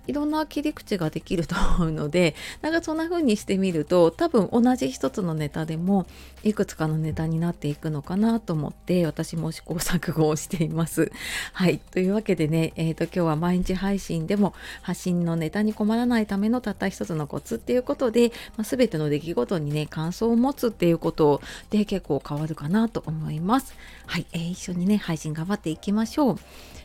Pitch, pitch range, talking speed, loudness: 175 Hz, 160-215 Hz, 390 characters per minute, -25 LUFS